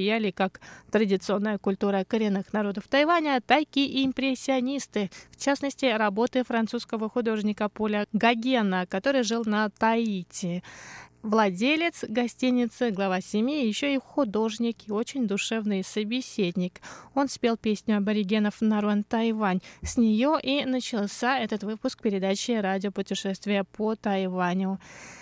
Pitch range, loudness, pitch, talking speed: 205-250 Hz, -27 LUFS, 220 Hz, 115 wpm